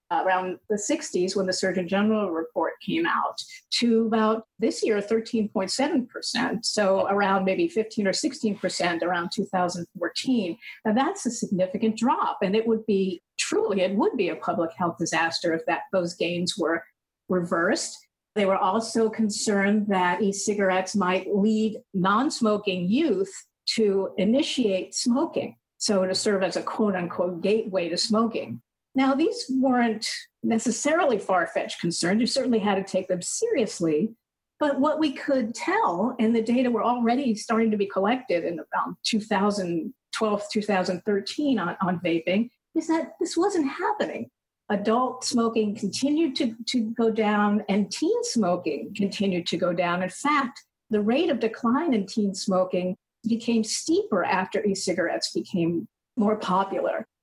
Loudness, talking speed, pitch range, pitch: -25 LUFS, 145 wpm, 190-245 Hz, 215 Hz